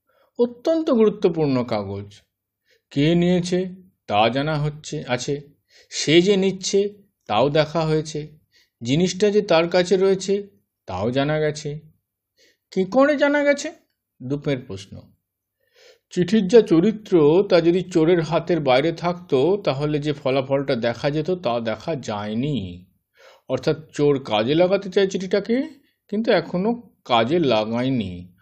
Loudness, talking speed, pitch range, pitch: -21 LUFS, 120 wpm, 130-200 Hz, 160 Hz